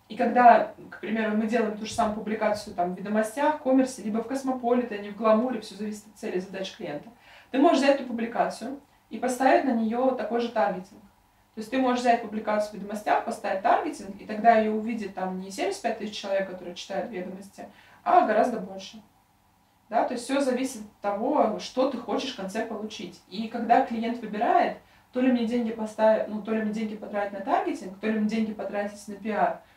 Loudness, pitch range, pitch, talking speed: -26 LUFS, 205-245 Hz, 220 Hz, 205 wpm